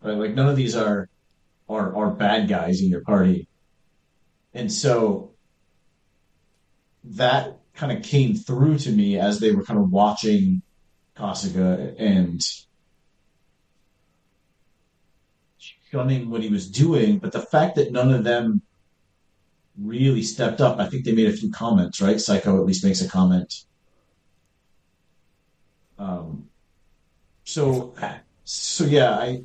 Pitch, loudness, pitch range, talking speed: 110 Hz, -21 LUFS, 95-145 Hz, 130 wpm